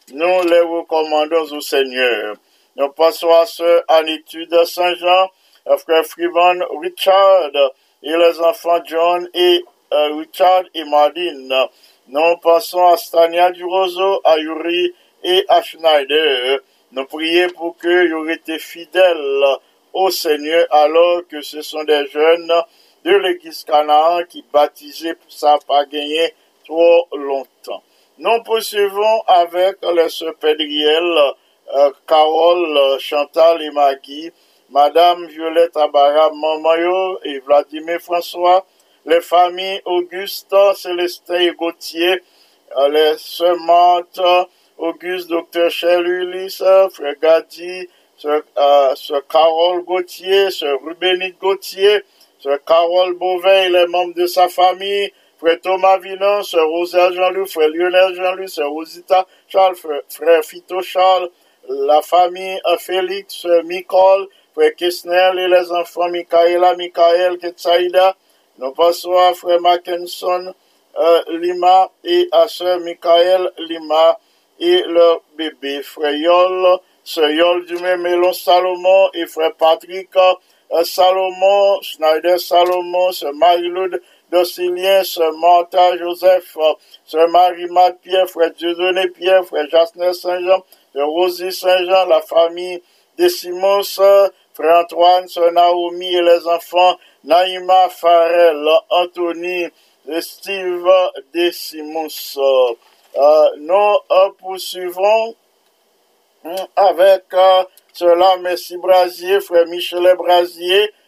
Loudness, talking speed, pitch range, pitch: -15 LUFS, 115 wpm, 165-185 Hz, 175 Hz